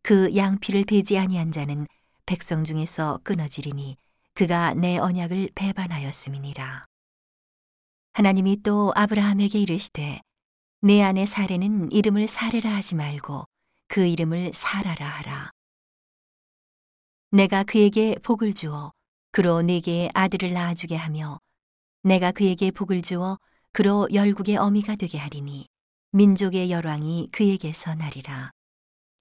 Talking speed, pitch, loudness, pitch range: 270 characters per minute, 180 Hz, -23 LUFS, 155-200 Hz